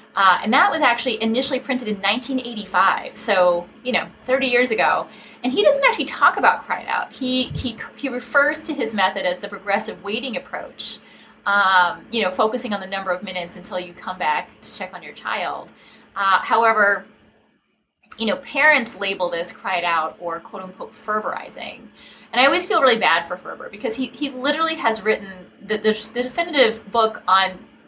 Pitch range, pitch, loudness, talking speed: 190-255 Hz, 220 Hz, -20 LUFS, 185 wpm